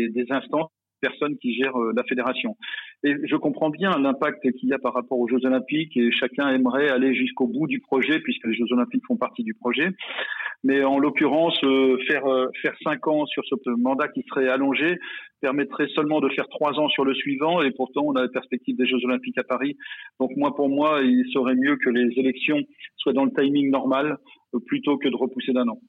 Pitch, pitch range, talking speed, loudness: 135 Hz, 130-150 Hz, 210 wpm, -23 LUFS